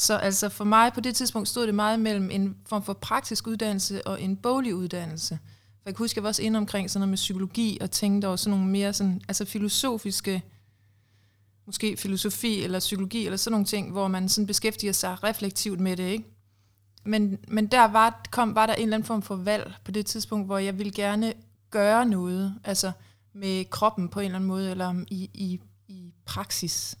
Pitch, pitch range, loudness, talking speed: 200 Hz, 185-215 Hz, -26 LUFS, 210 wpm